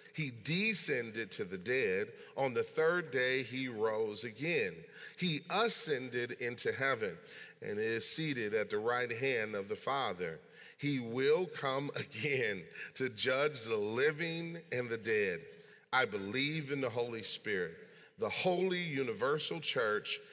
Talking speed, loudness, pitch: 140 wpm, -35 LUFS, 160 Hz